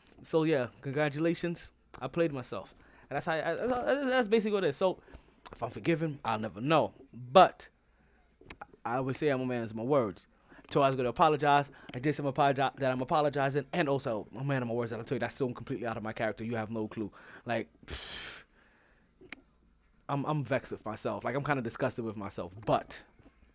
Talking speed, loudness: 210 wpm, -32 LUFS